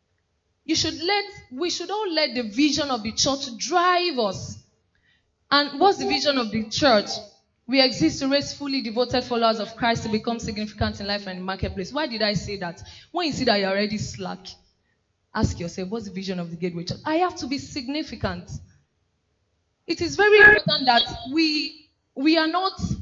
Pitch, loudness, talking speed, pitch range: 255 Hz, -22 LUFS, 195 wpm, 205-315 Hz